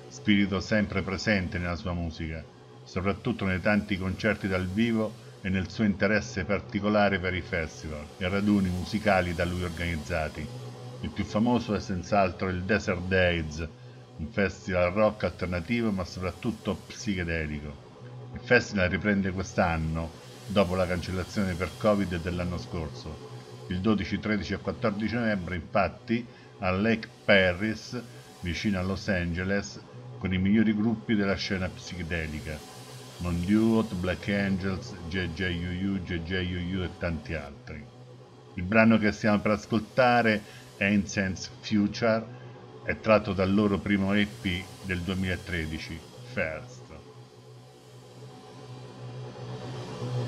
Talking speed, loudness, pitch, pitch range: 120 wpm, -28 LUFS, 95 Hz, 80-105 Hz